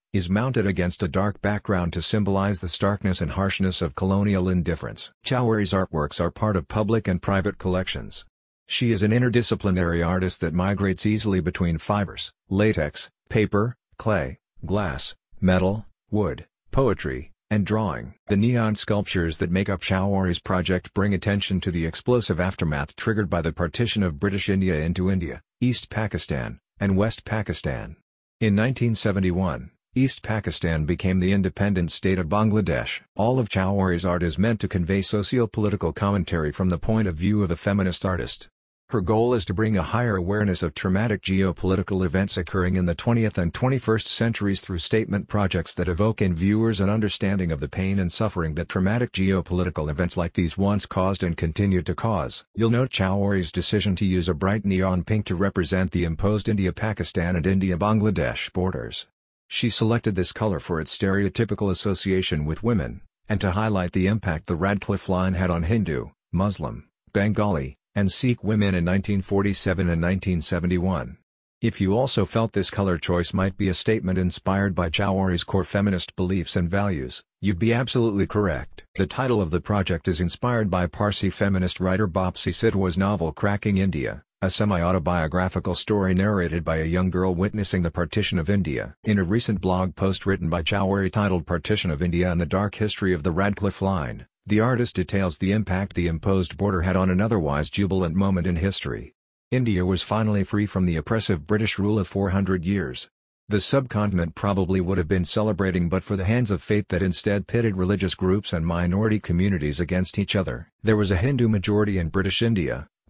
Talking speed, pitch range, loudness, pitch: 175 wpm, 90-105 Hz, -24 LUFS, 95 Hz